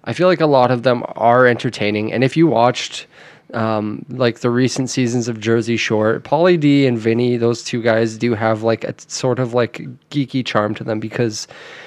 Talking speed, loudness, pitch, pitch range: 200 wpm, -17 LUFS, 120 Hz, 115-130 Hz